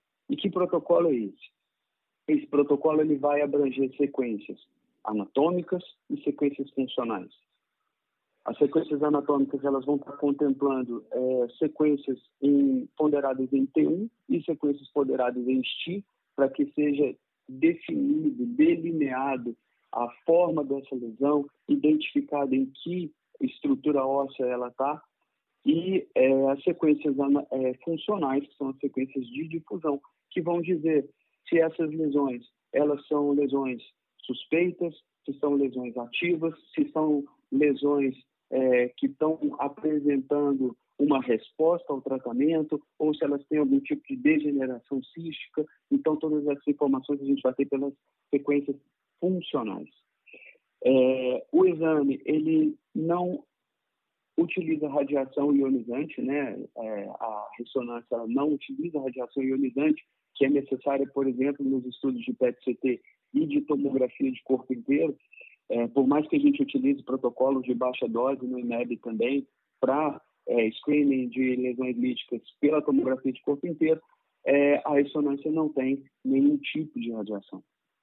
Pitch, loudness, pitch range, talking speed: 145 Hz, -27 LUFS, 135-165 Hz, 130 wpm